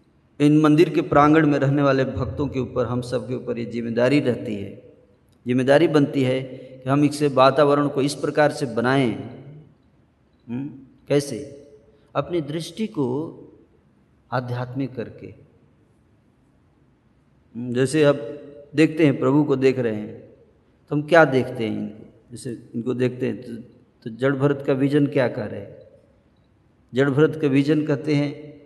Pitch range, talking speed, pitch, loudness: 125-145 Hz, 150 wpm, 135 Hz, -21 LUFS